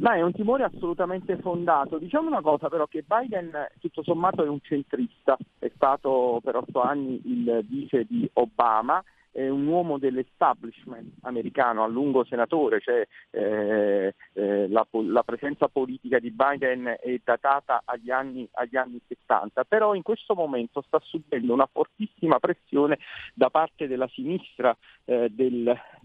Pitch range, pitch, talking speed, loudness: 125-175 Hz, 140 Hz, 150 wpm, -26 LUFS